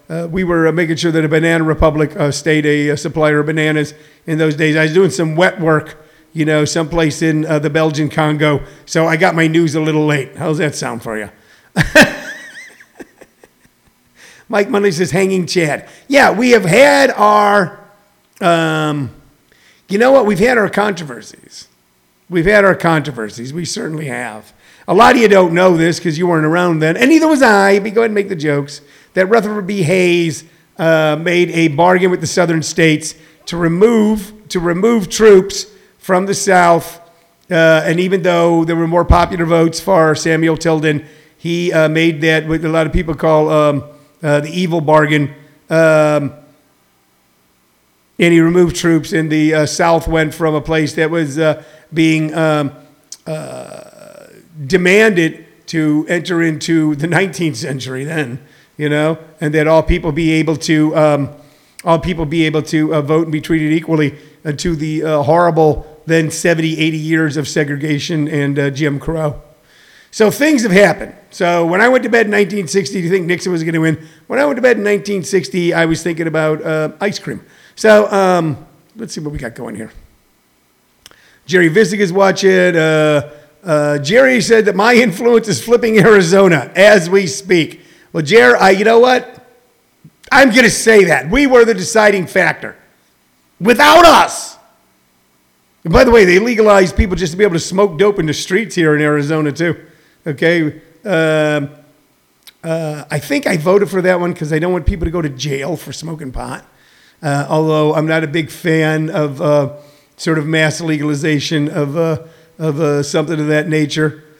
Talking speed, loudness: 180 wpm, -13 LUFS